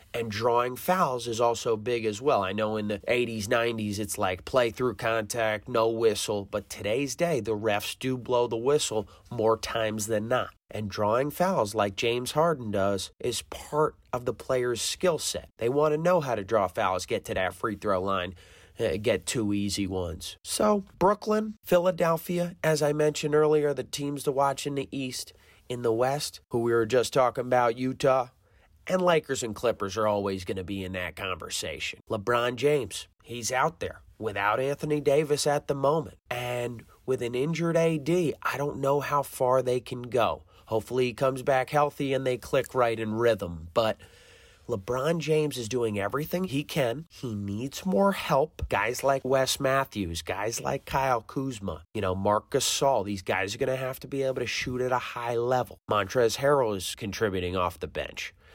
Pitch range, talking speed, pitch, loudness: 105-140 Hz, 190 wpm, 120 Hz, -28 LUFS